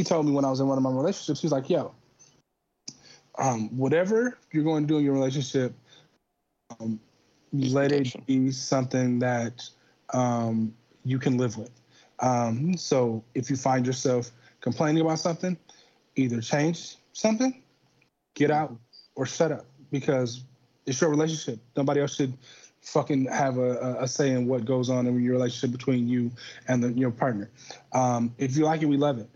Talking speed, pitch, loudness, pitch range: 175 wpm, 130 Hz, -27 LUFS, 125-150 Hz